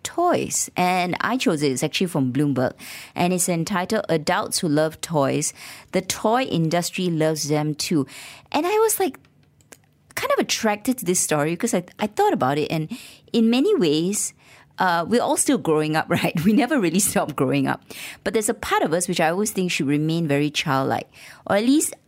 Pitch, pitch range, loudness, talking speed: 175 Hz, 150-215 Hz, -22 LUFS, 200 wpm